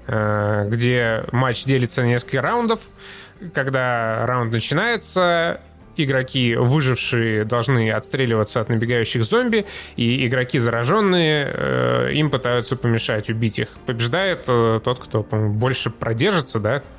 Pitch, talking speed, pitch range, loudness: 120 Hz, 105 wpm, 115-135 Hz, -20 LUFS